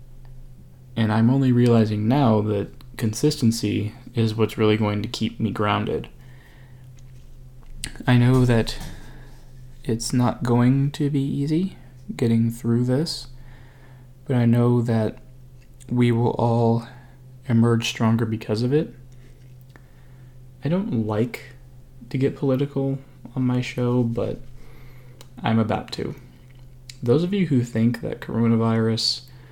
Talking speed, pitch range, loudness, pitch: 120 wpm, 115-130 Hz, -22 LUFS, 125 Hz